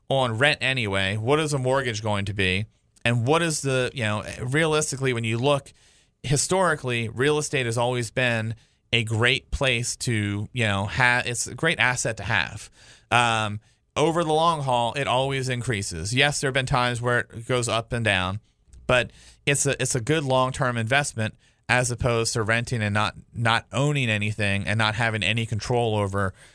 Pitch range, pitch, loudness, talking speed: 110-135 Hz, 120 Hz, -23 LUFS, 185 wpm